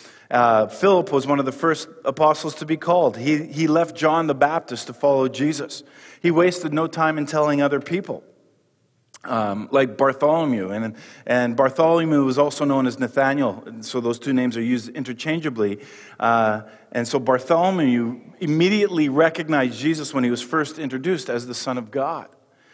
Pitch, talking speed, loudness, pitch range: 145 Hz, 170 wpm, -21 LUFS, 125-160 Hz